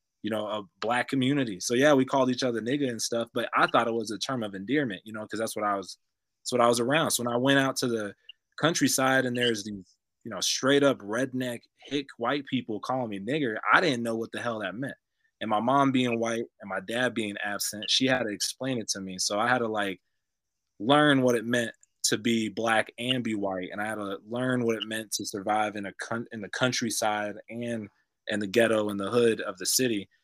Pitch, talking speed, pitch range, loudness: 115 Hz, 245 wpm, 105-125 Hz, -27 LUFS